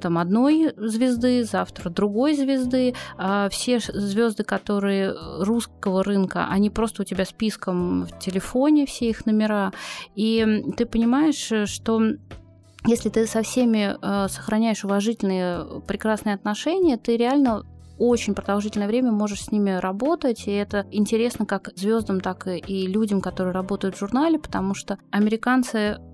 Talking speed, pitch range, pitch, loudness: 135 wpm, 195-235 Hz, 215 Hz, -23 LUFS